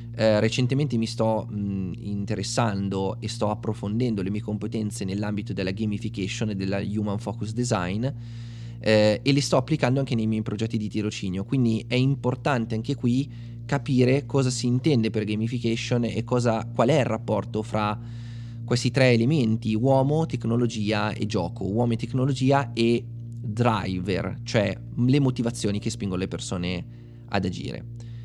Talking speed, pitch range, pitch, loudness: 145 wpm, 105-120 Hz, 115 Hz, -25 LUFS